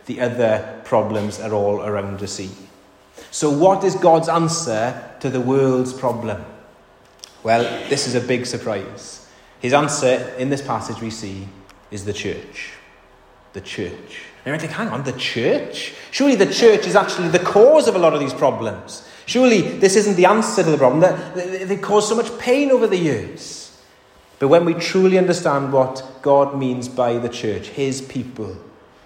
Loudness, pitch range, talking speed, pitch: -18 LUFS, 110-180 Hz, 175 wpm, 130 Hz